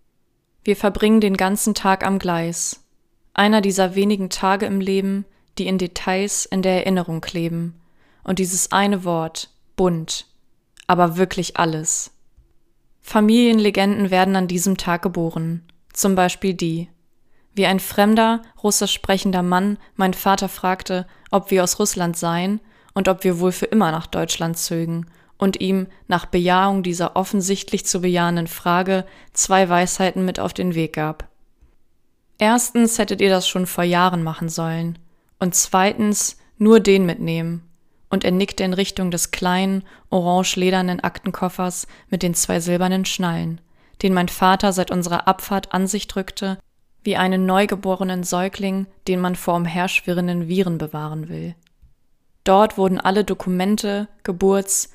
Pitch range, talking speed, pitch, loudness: 175-195 Hz, 140 wpm, 185 Hz, -19 LUFS